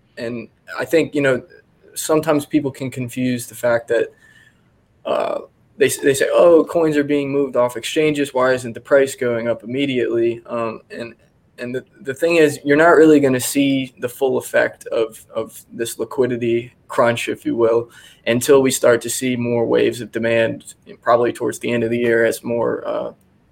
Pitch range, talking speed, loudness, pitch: 120-145 Hz, 190 wpm, -18 LUFS, 130 Hz